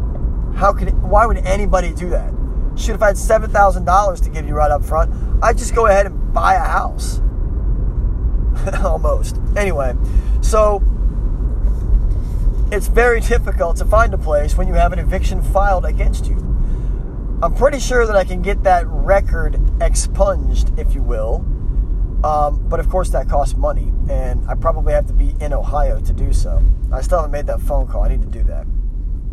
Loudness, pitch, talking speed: -18 LUFS, 90 Hz, 180 wpm